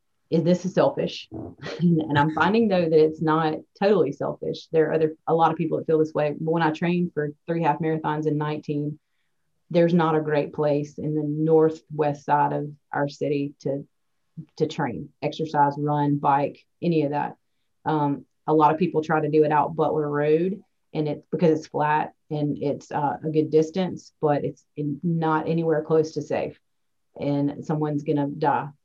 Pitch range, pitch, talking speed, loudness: 145-160 Hz, 155 Hz, 185 wpm, -24 LUFS